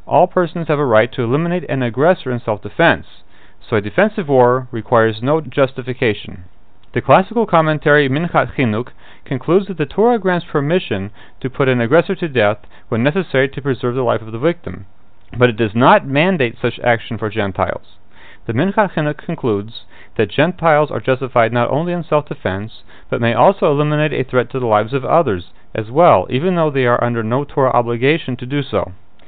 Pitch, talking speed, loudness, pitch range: 130 Hz, 185 wpm, -16 LUFS, 110-150 Hz